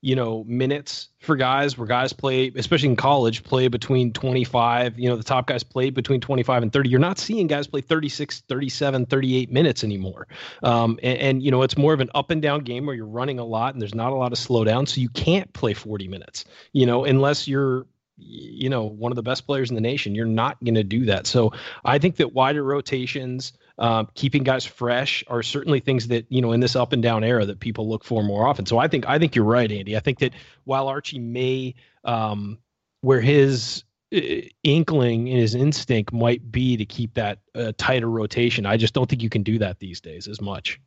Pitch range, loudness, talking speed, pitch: 115-135 Hz, -22 LUFS, 230 wpm, 125 Hz